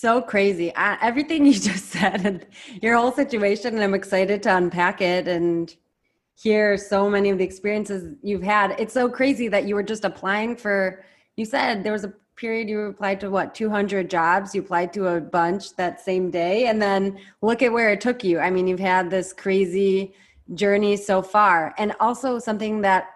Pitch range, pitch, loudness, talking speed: 190-215 Hz, 200 Hz, -22 LUFS, 195 wpm